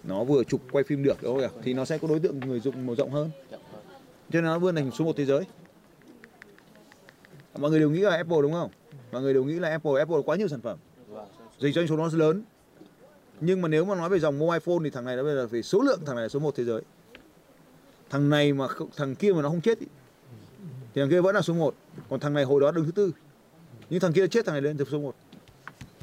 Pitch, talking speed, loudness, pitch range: 150 Hz, 265 wpm, -26 LUFS, 135-170 Hz